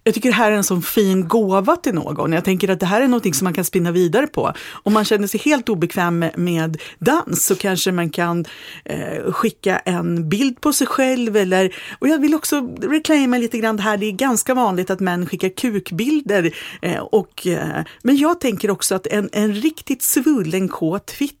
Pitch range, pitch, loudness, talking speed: 185-260 Hz, 210 Hz, -18 LUFS, 205 wpm